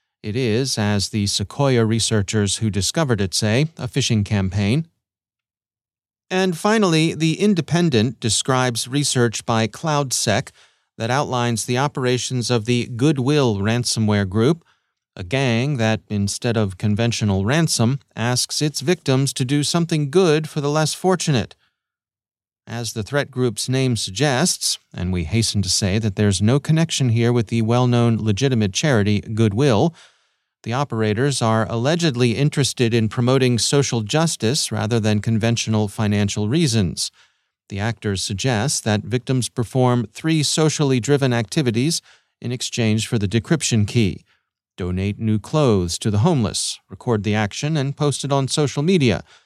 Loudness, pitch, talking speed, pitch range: -19 LUFS, 120 Hz, 140 wpm, 110-145 Hz